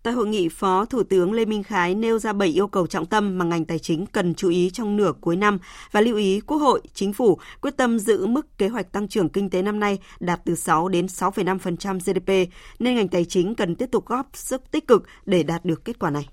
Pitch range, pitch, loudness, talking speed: 180-220 Hz, 195 Hz, -22 LUFS, 255 wpm